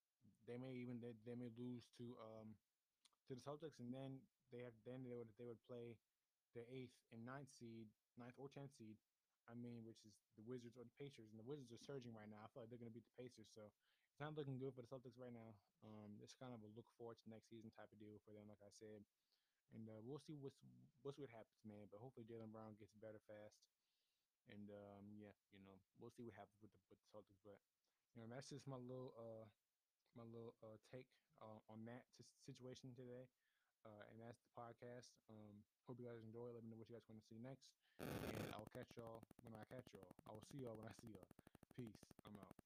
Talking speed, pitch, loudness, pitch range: 240 wpm, 115 Hz, -60 LUFS, 110-125 Hz